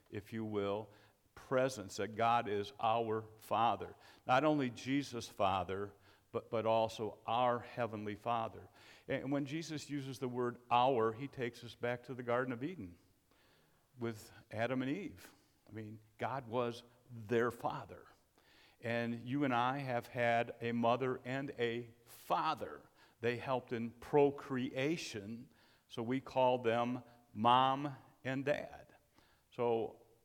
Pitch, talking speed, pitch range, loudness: 120 Hz, 135 wpm, 110-130 Hz, -38 LUFS